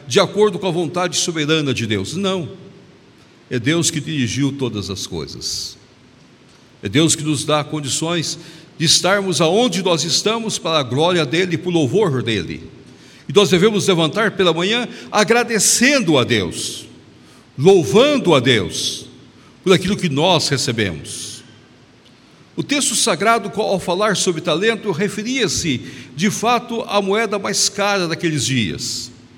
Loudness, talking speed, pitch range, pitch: -17 LUFS, 140 wpm, 135-200 Hz, 170 Hz